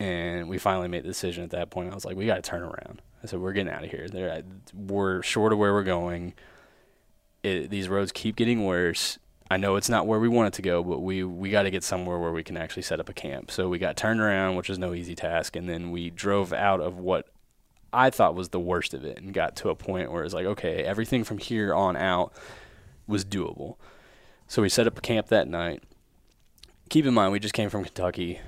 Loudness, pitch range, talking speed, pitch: -27 LUFS, 90-100 Hz, 250 wpm, 95 Hz